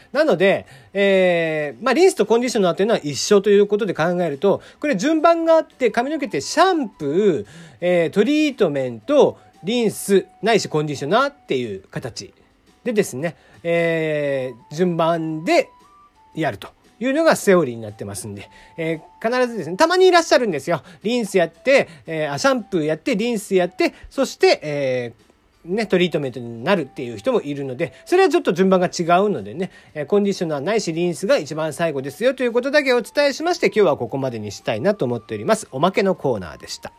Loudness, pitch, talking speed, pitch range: -19 LUFS, 190 Hz, 420 characters per minute, 155-250 Hz